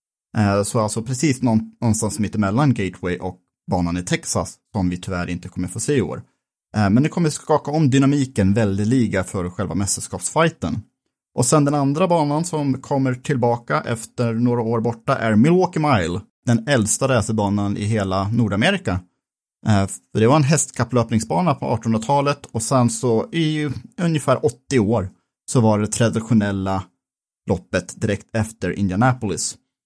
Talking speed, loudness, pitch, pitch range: 150 wpm, -20 LUFS, 115 Hz, 100-135 Hz